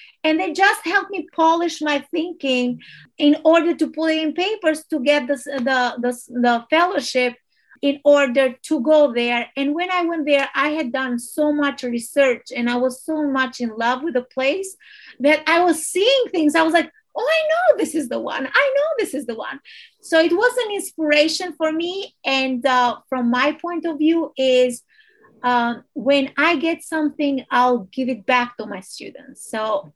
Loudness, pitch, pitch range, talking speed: -19 LUFS, 295 Hz, 255-330 Hz, 190 wpm